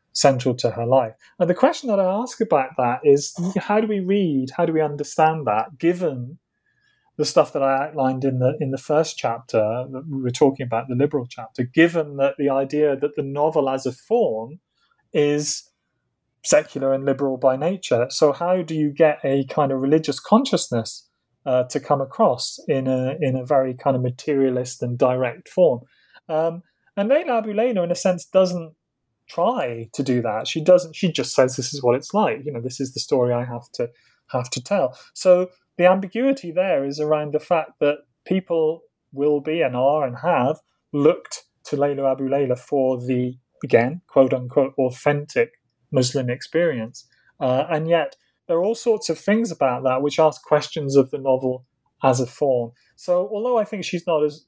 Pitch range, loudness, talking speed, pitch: 130-170 Hz, -21 LUFS, 190 wpm, 145 Hz